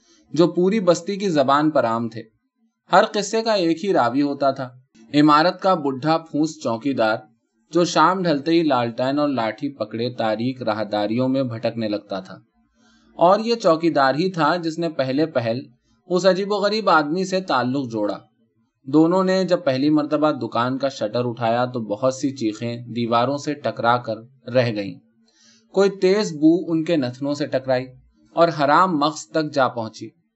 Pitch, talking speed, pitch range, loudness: 140 Hz, 170 wpm, 115-170 Hz, -20 LUFS